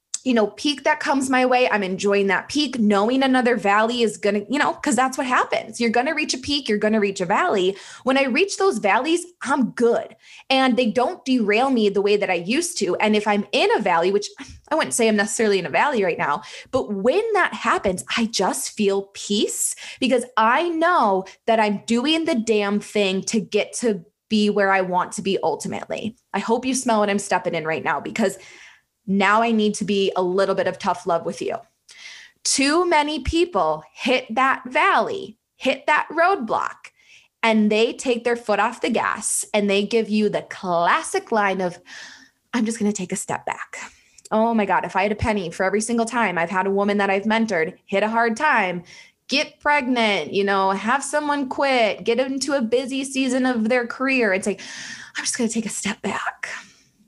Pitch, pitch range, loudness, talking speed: 225 Hz, 200-265 Hz, -21 LUFS, 210 wpm